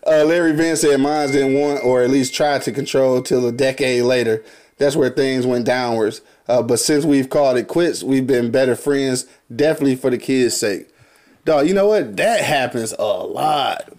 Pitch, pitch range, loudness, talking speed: 135 Hz, 125-150 Hz, -17 LUFS, 195 wpm